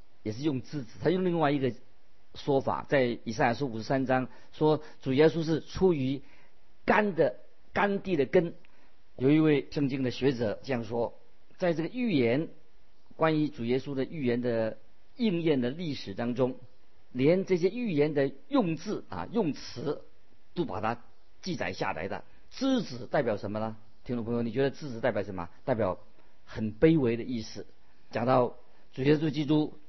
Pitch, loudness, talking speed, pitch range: 135 Hz, -30 LUFS, 245 characters per minute, 120-155 Hz